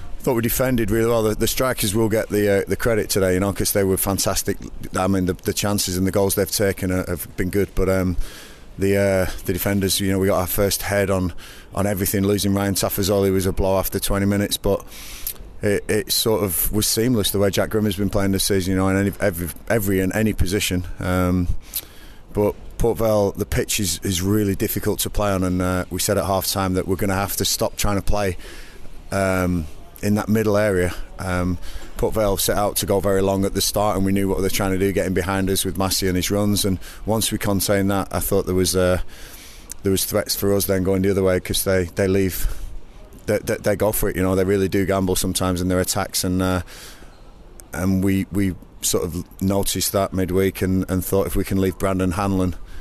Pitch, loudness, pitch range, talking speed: 95 Hz, -21 LUFS, 95-100 Hz, 235 wpm